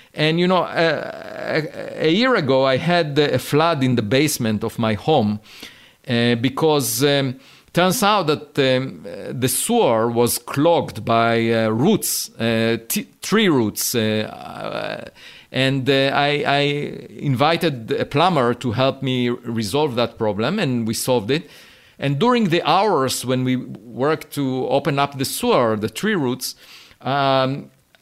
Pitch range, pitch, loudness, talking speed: 120-150 Hz, 135 Hz, -19 LUFS, 135 wpm